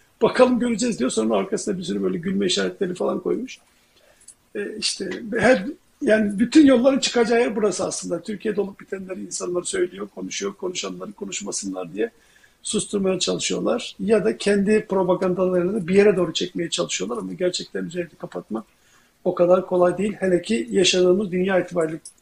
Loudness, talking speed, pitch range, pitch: -22 LUFS, 150 wpm, 180-215 Hz, 190 Hz